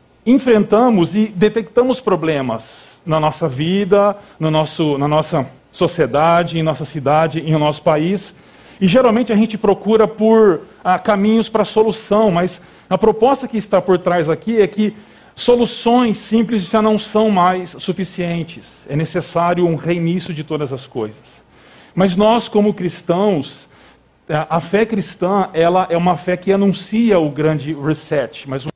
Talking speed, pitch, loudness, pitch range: 150 wpm, 180 Hz, -16 LUFS, 155-215 Hz